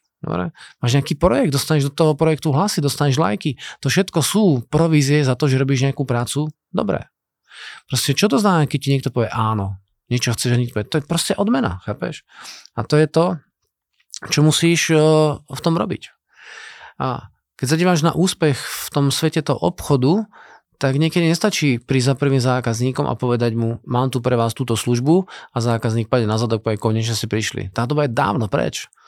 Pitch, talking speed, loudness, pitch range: 140 Hz, 185 wpm, -19 LUFS, 120-160 Hz